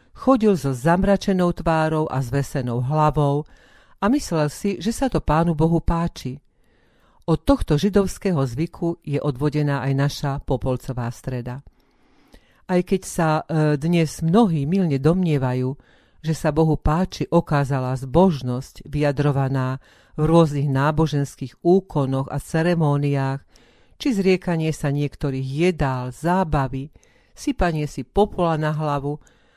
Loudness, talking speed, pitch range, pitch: -21 LUFS, 120 wpm, 140-170 Hz, 150 Hz